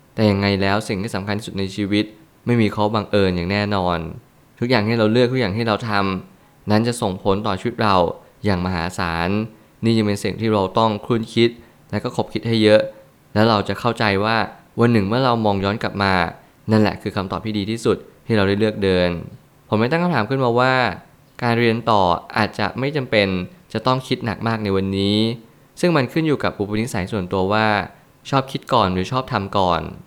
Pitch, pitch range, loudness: 110 Hz, 100-120 Hz, -20 LUFS